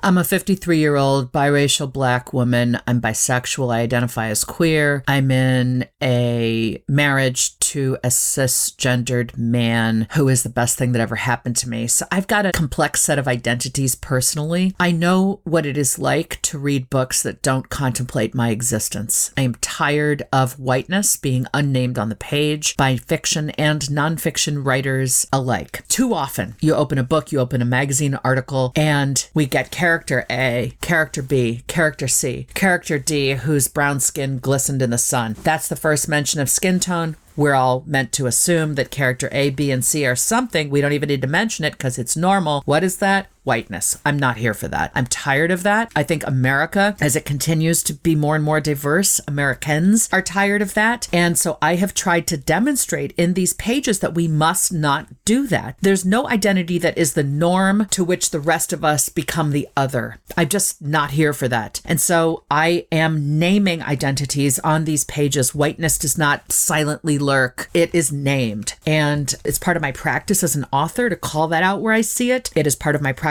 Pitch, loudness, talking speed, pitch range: 145 Hz, -18 LUFS, 195 wpm, 130-165 Hz